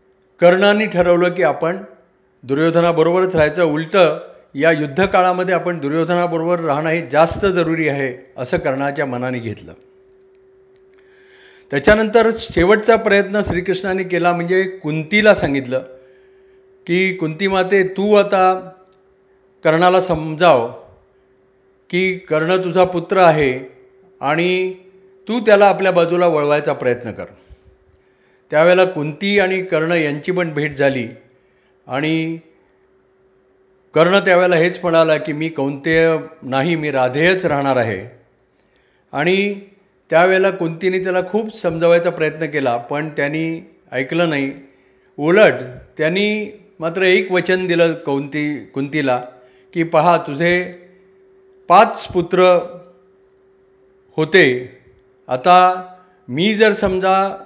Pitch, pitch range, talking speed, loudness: 175 Hz, 145-190 Hz, 105 wpm, -16 LUFS